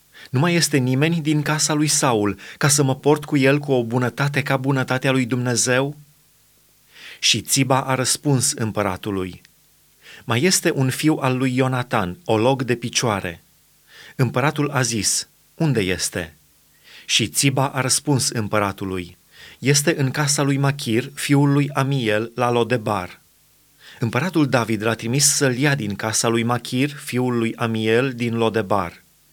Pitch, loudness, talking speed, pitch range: 130 Hz, -20 LUFS, 145 wpm, 115-140 Hz